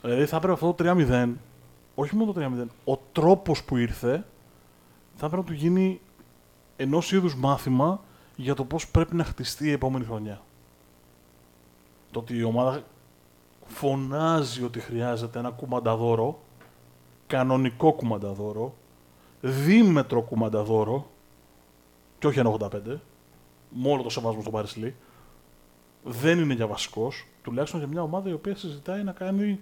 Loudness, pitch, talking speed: -26 LUFS, 120 Hz, 135 wpm